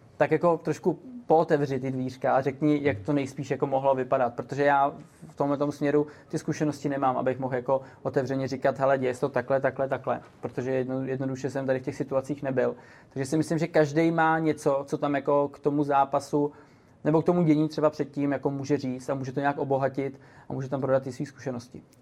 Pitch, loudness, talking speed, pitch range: 140 Hz, -27 LUFS, 210 wpm, 135-150 Hz